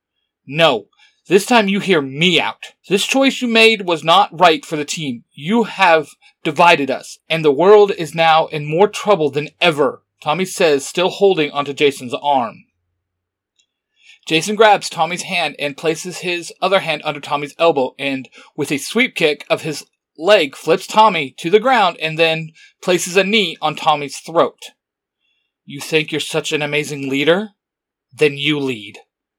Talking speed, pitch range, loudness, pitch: 165 wpm, 145-190 Hz, -16 LUFS, 160 Hz